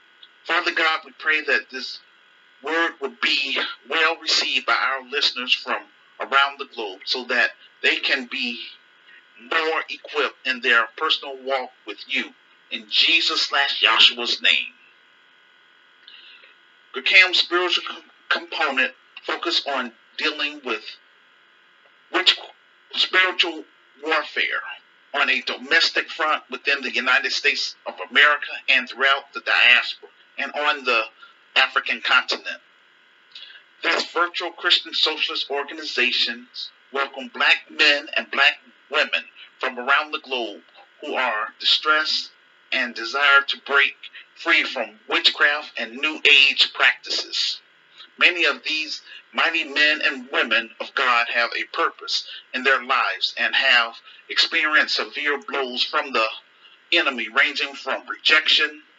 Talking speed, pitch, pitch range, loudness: 120 wpm, 155 Hz, 140-185 Hz, -20 LUFS